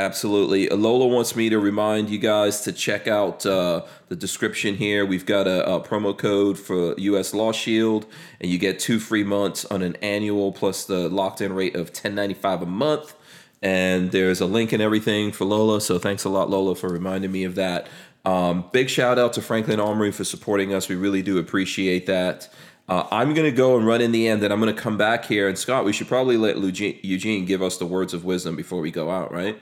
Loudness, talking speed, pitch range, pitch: -22 LUFS, 225 wpm, 95-110 Hz, 100 Hz